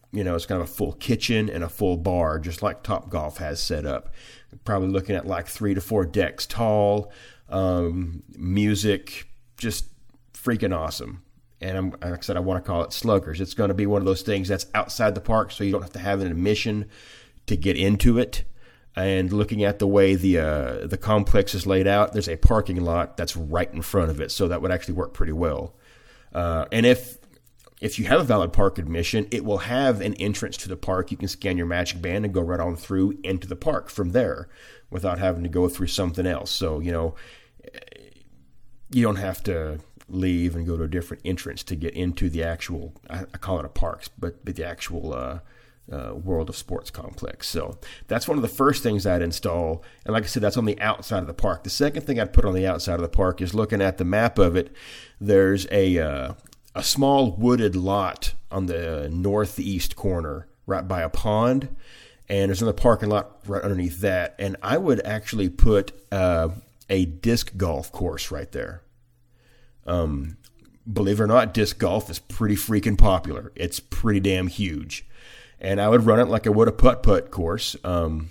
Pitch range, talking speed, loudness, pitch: 85-105 Hz, 210 wpm, -24 LUFS, 95 Hz